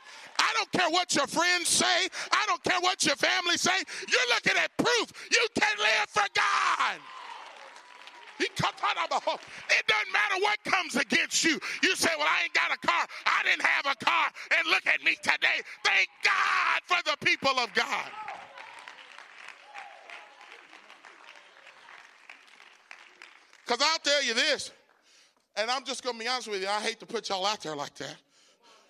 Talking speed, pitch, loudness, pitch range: 170 wpm, 330 Hz, -26 LUFS, 255-375 Hz